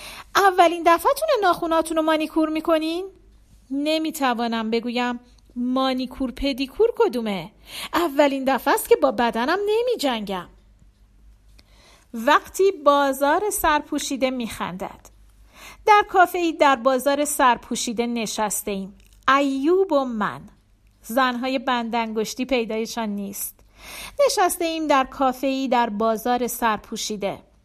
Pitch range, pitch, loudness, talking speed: 235-320 Hz, 270 Hz, -21 LUFS, 100 wpm